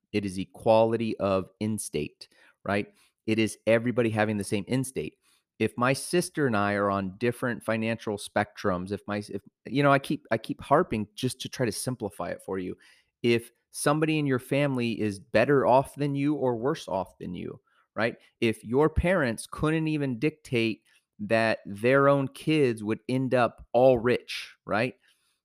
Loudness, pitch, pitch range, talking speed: -27 LUFS, 115 Hz, 105-135 Hz, 170 wpm